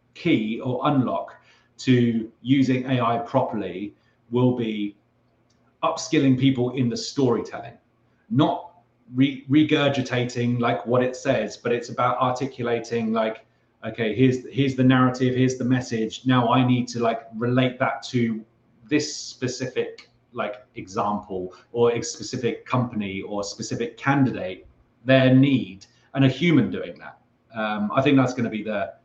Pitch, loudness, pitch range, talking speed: 125 Hz, -23 LUFS, 115-130 Hz, 140 wpm